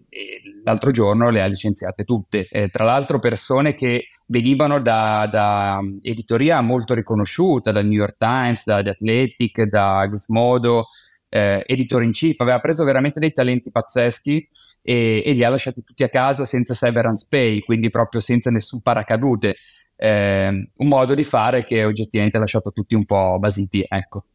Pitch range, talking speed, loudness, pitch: 105-130 Hz, 165 wpm, -19 LUFS, 115 Hz